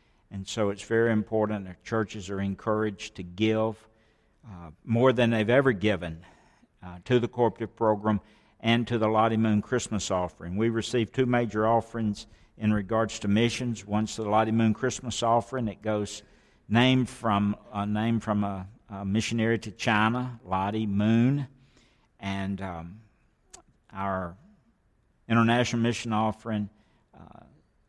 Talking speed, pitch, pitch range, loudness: 140 wpm, 110 Hz, 100-115 Hz, -27 LUFS